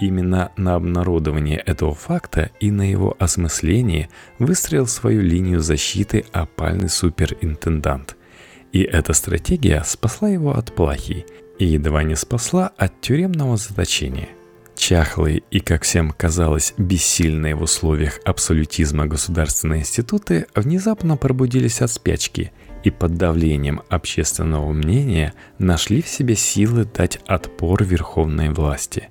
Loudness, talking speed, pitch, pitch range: -19 LUFS, 120 wpm, 90 Hz, 80-105 Hz